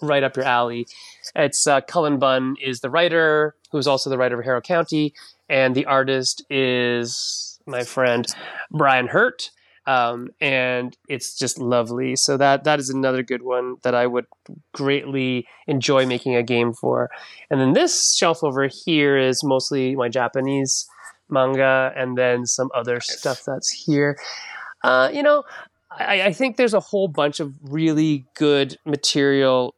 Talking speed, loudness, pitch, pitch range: 160 wpm, -20 LUFS, 135 Hz, 125-150 Hz